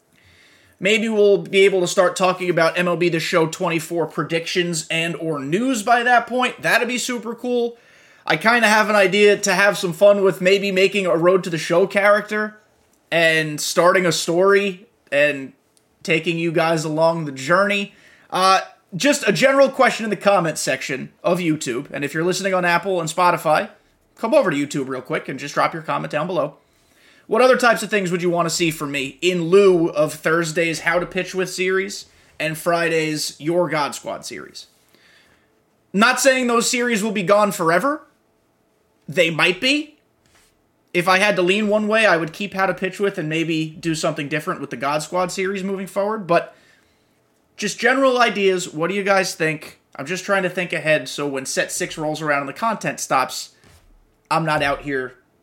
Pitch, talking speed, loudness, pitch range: 180 Hz, 190 wpm, -19 LUFS, 160-205 Hz